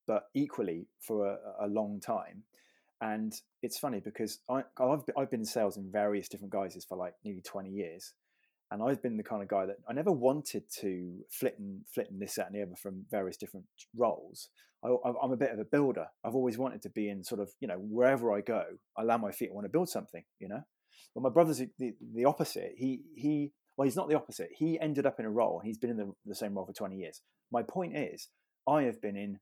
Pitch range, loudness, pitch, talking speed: 100-140 Hz, -35 LUFS, 115 Hz, 245 wpm